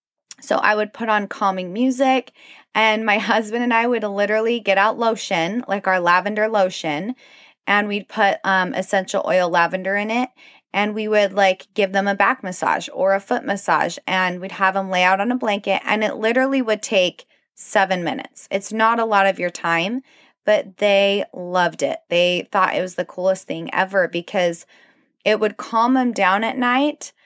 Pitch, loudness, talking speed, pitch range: 205 Hz, -19 LUFS, 190 wpm, 185-230 Hz